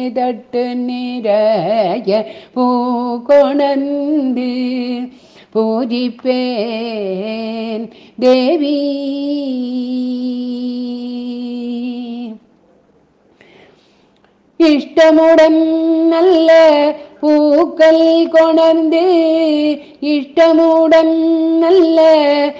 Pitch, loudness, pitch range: 275 Hz, -13 LUFS, 245-320 Hz